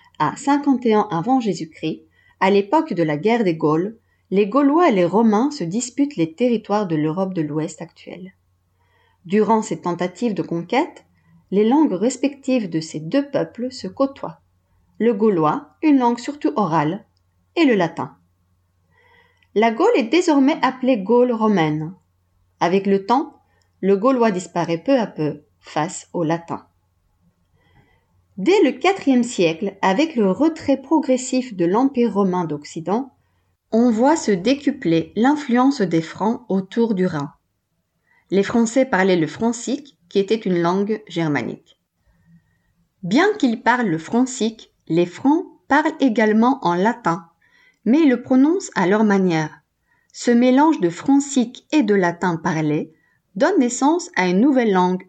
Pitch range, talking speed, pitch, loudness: 165-260 Hz, 145 wpm, 205 Hz, -19 LUFS